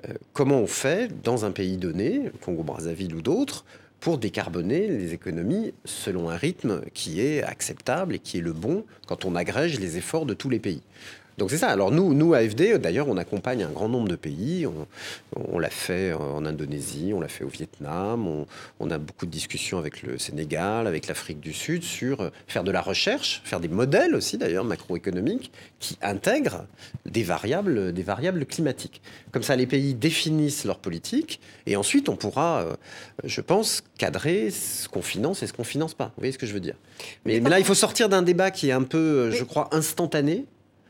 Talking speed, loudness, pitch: 200 wpm, -26 LUFS, 125 Hz